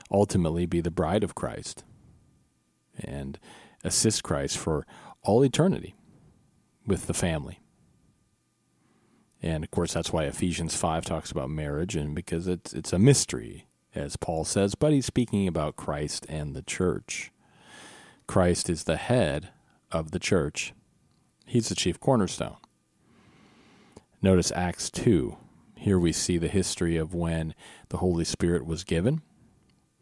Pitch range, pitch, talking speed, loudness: 80-95 Hz, 85 Hz, 135 wpm, -27 LUFS